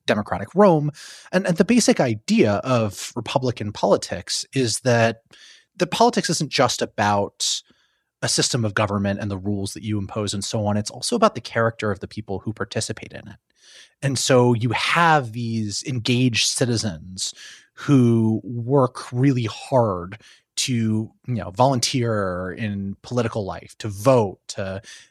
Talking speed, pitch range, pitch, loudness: 150 wpm, 105-130 Hz, 115 Hz, -21 LUFS